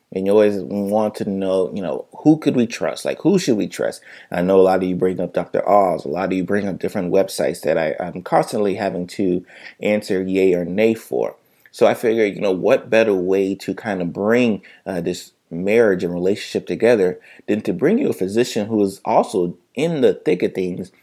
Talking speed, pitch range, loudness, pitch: 225 wpm, 90-105 Hz, -19 LUFS, 95 Hz